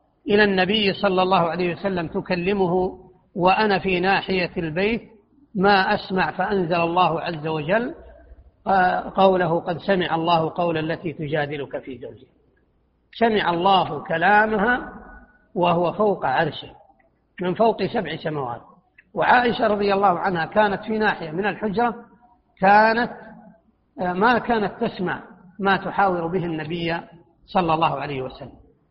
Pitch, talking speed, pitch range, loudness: 190 Hz, 120 wpm, 170-210 Hz, -21 LUFS